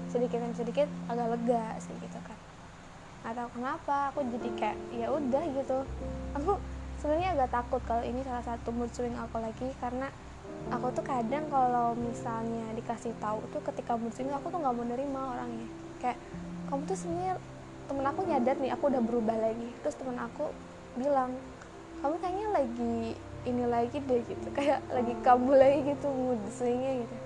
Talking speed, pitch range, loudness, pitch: 170 wpm, 235-275 Hz, -32 LUFS, 250 Hz